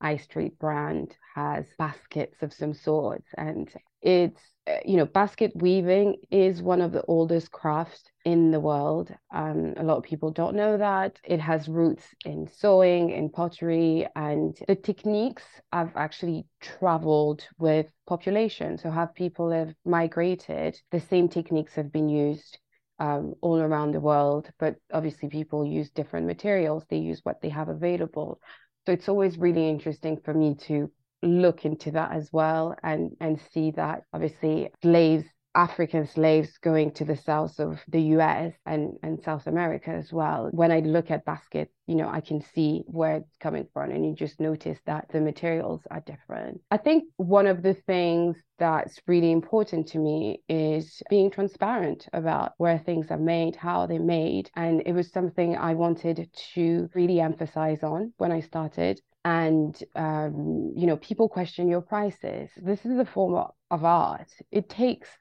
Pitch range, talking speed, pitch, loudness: 155-175 Hz, 170 wpm, 165 Hz, -26 LUFS